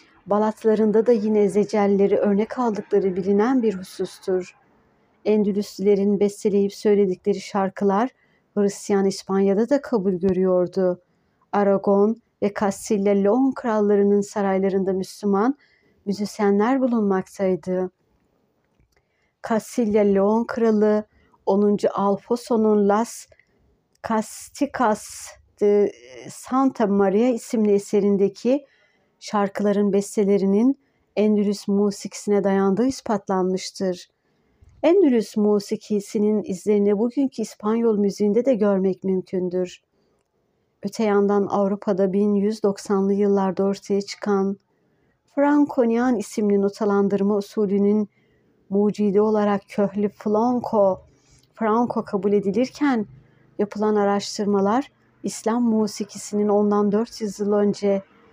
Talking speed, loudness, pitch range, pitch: 80 wpm, -21 LUFS, 200-220 Hz, 205 Hz